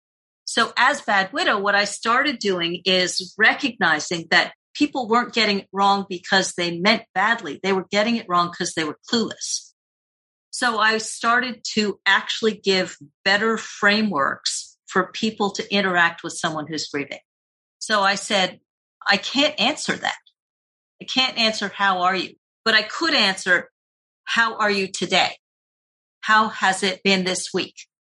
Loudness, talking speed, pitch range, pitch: -20 LUFS, 155 wpm, 185-220 Hz, 200 Hz